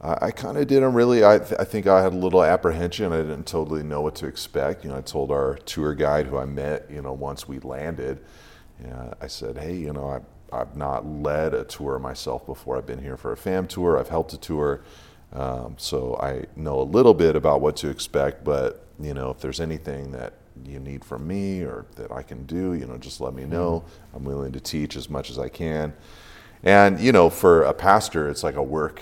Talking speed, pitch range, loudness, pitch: 235 wpm, 65-85 Hz, -23 LUFS, 75 Hz